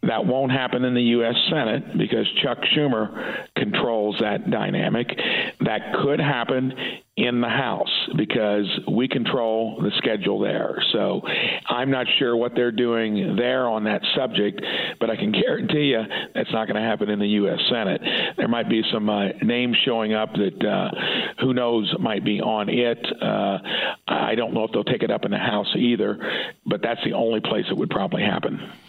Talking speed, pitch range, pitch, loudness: 185 wpm, 110-125 Hz, 120 Hz, -22 LUFS